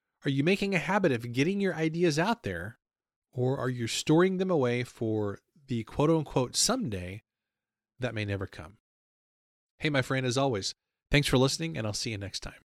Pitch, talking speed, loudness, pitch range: 130 Hz, 190 wpm, -29 LUFS, 110-160 Hz